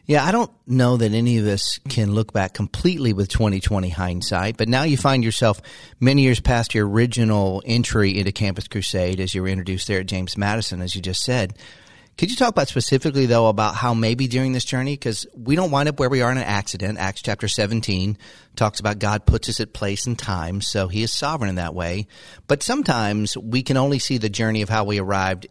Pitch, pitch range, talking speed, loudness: 110 Hz, 100-125 Hz, 225 wpm, -21 LUFS